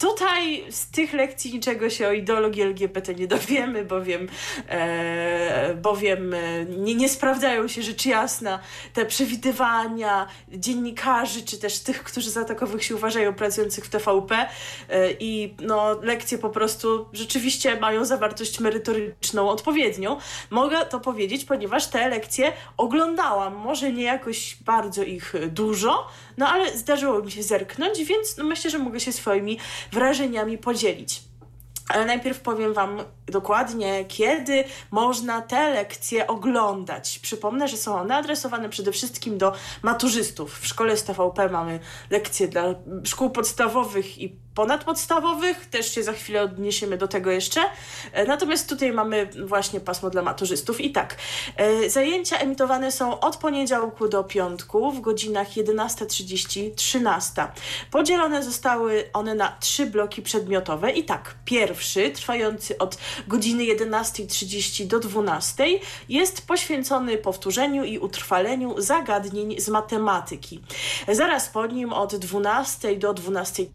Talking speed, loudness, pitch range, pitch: 130 wpm, -24 LUFS, 200-255 Hz, 220 Hz